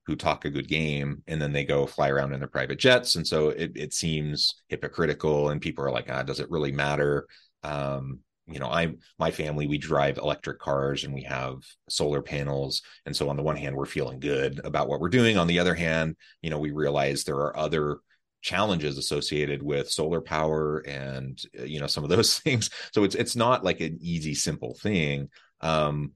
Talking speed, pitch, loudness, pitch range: 210 wpm, 75 Hz, -27 LUFS, 70-80 Hz